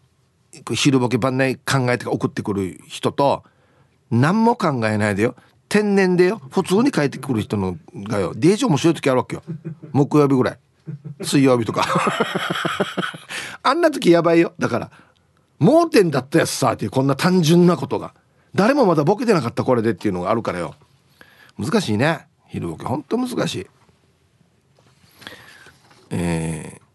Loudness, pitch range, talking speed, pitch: -19 LUFS, 125-175 Hz, 295 characters per minute, 140 Hz